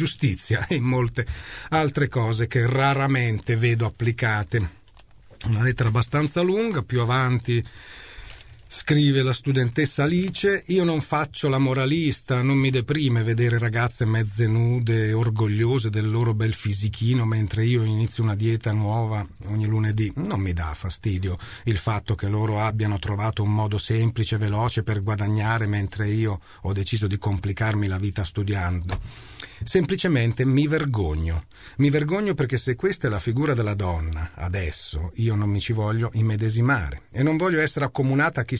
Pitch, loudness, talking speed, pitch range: 115 Hz, -23 LUFS, 150 wpm, 105-130 Hz